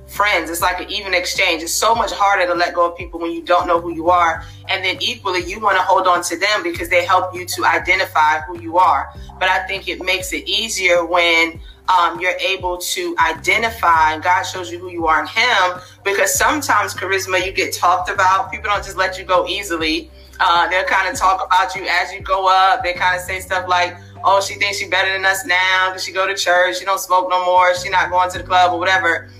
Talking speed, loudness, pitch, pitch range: 245 wpm, -16 LUFS, 180 Hz, 175-190 Hz